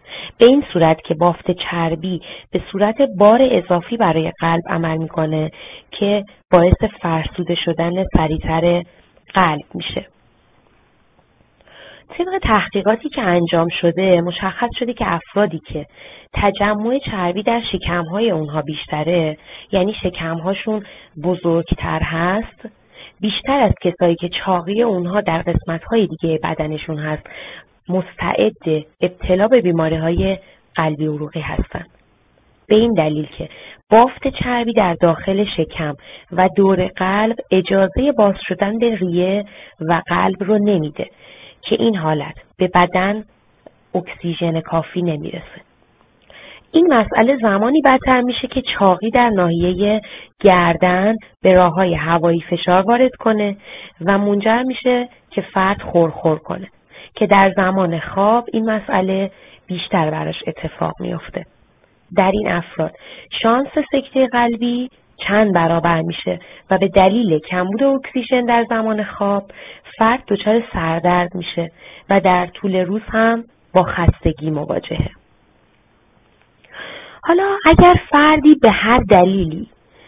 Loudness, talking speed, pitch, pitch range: -17 LUFS, 120 wpm, 190 Hz, 170-220 Hz